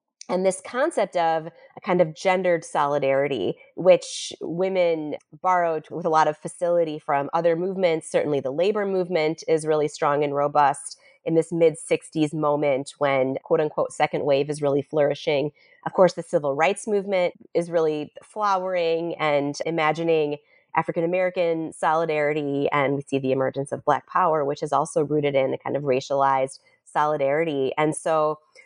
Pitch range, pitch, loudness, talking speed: 145-175 Hz, 160 Hz, -23 LUFS, 160 wpm